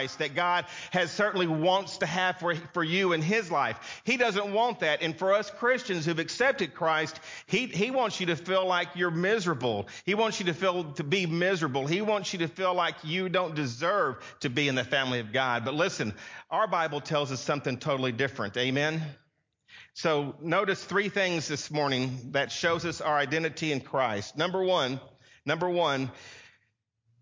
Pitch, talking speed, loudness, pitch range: 165 Hz, 185 wpm, -28 LUFS, 140-185 Hz